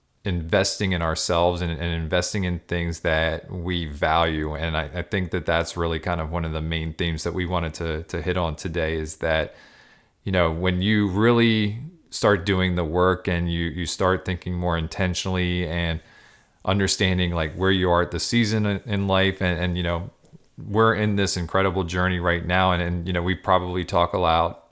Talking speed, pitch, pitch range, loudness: 200 wpm, 90 Hz, 85-95 Hz, -23 LUFS